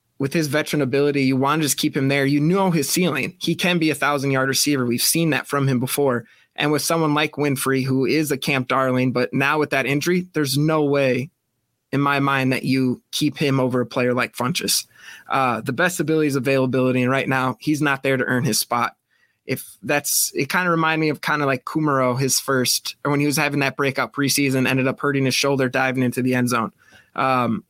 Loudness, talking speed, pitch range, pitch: -20 LUFS, 230 wpm, 130-150 Hz, 140 Hz